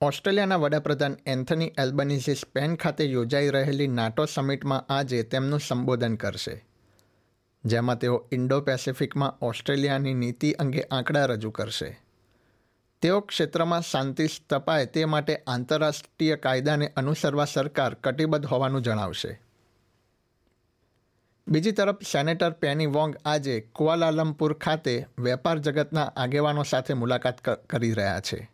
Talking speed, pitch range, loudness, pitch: 110 wpm, 120-150 Hz, -26 LUFS, 135 Hz